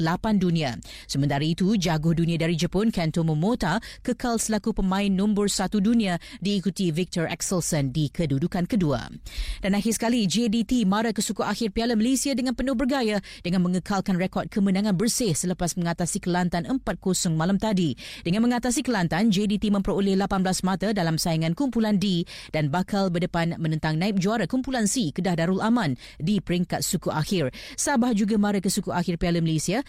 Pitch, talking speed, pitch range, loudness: 190 Hz, 160 wpm, 170-220 Hz, -24 LUFS